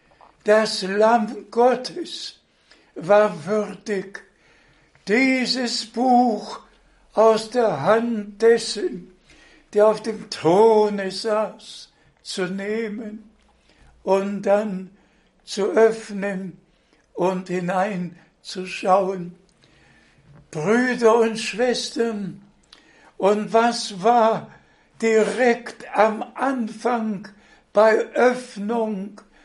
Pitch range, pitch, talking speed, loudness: 195-230 Hz, 215 Hz, 70 wpm, -21 LUFS